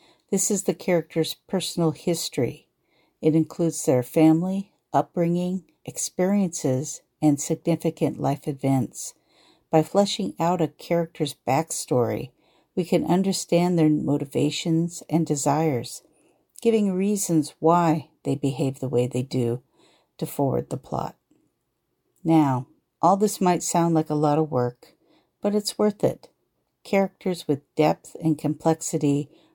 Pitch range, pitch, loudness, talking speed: 150-175 Hz, 160 Hz, -24 LUFS, 125 wpm